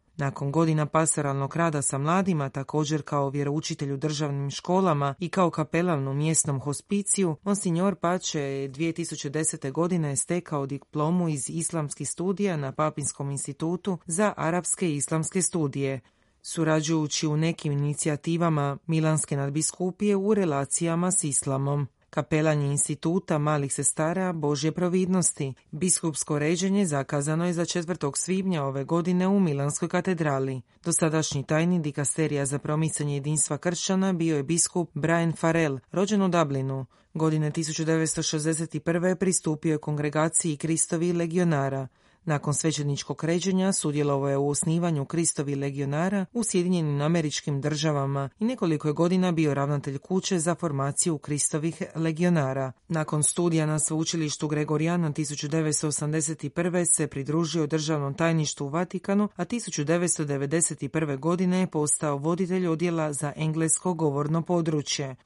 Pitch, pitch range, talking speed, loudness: 160 Hz, 145-175 Hz, 120 wpm, -26 LUFS